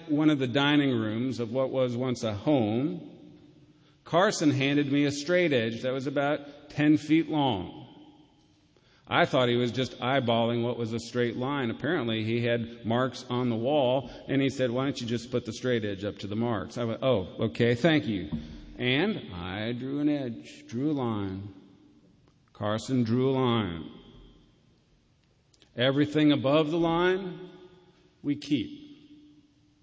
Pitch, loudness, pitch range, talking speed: 130 Hz, -28 LUFS, 115-150 Hz, 160 wpm